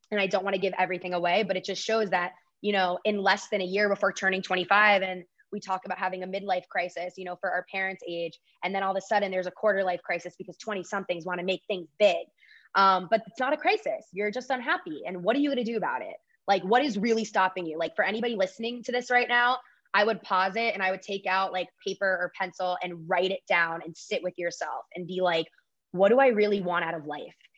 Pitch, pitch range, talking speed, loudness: 190 Hz, 180-210 Hz, 255 wpm, -27 LUFS